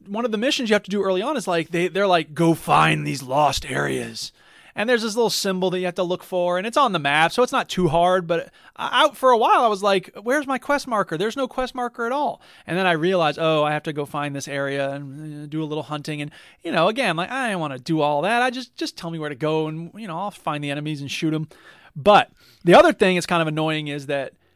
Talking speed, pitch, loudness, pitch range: 285 wpm, 175 Hz, -21 LUFS, 155-220 Hz